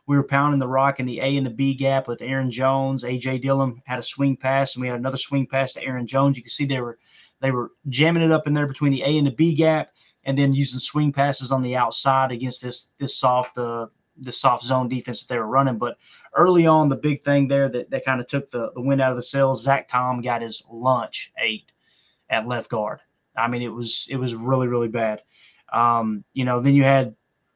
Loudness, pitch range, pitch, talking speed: -21 LUFS, 125-140 Hz, 135 Hz, 245 wpm